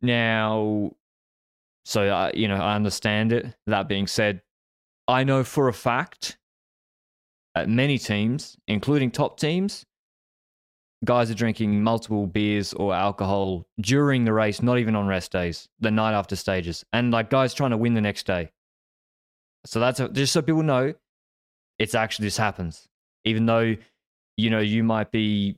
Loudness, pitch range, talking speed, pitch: -24 LUFS, 100-120 Hz, 160 wpm, 110 Hz